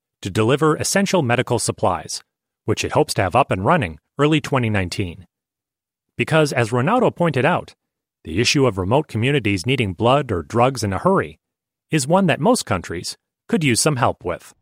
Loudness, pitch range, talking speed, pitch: -19 LUFS, 105-150 Hz, 170 wpm, 125 Hz